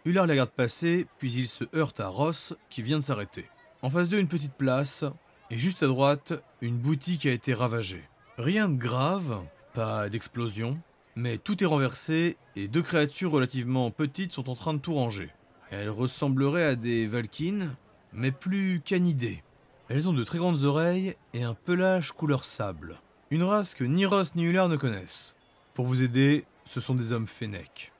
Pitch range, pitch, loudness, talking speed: 120-170 Hz, 140 Hz, -29 LUFS, 180 wpm